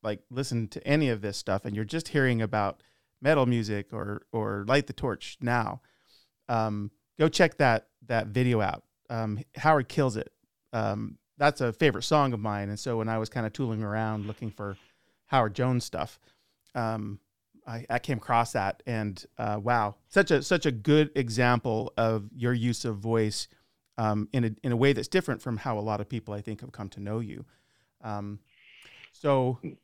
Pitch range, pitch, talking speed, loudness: 105-130 Hz, 115 Hz, 190 wpm, -28 LUFS